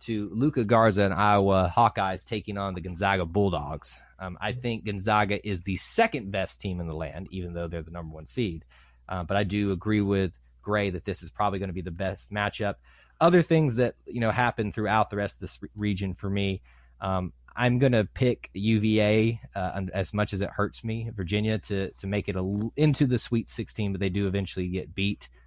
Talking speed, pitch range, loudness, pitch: 215 wpm, 95-110 Hz, -27 LUFS, 100 Hz